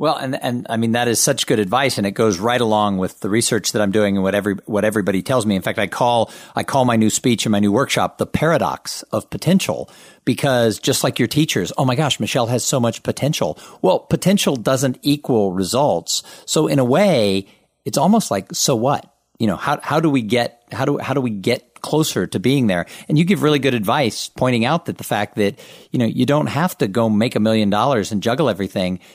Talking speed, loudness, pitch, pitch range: 235 wpm, -18 LUFS, 120 Hz, 105-140 Hz